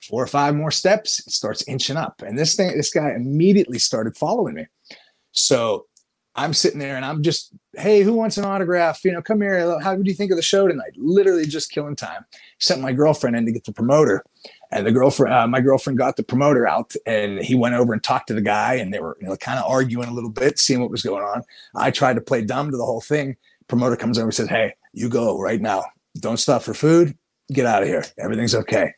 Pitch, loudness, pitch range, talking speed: 145 Hz, -20 LUFS, 120-175 Hz, 245 wpm